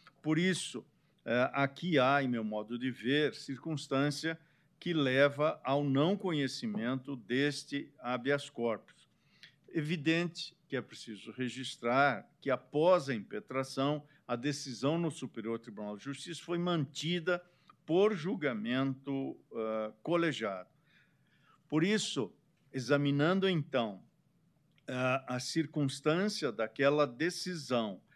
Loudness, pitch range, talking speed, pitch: -34 LUFS, 130-165 Hz, 100 wpm, 145 Hz